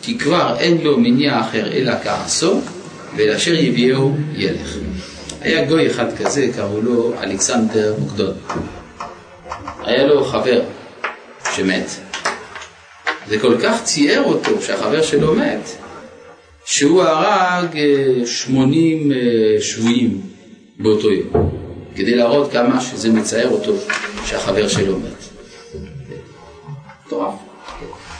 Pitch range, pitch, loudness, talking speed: 115-155 Hz, 135 Hz, -17 LUFS, 100 wpm